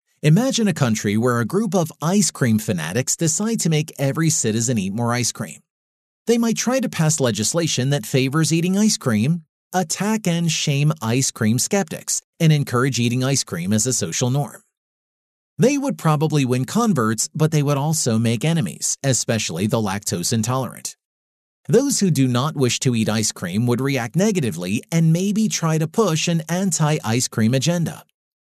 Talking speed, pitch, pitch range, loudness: 175 wpm, 150 Hz, 120-175 Hz, -20 LUFS